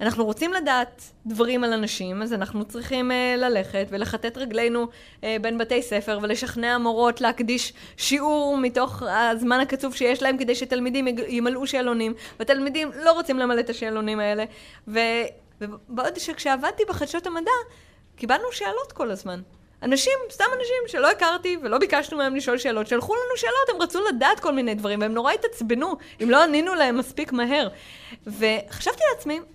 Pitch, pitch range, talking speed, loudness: 250 Hz, 225-295 Hz, 155 wpm, -24 LUFS